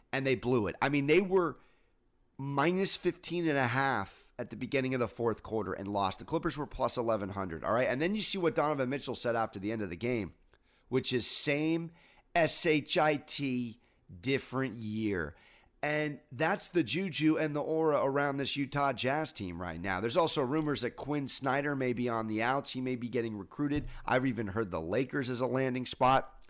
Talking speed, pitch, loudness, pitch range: 200 wpm, 130 Hz, -32 LUFS, 115-145 Hz